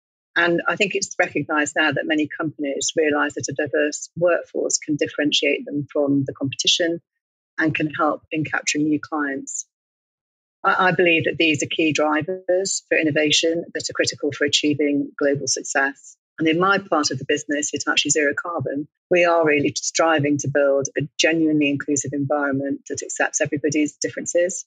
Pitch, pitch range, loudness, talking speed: 150 Hz, 145-165 Hz, -20 LUFS, 165 wpm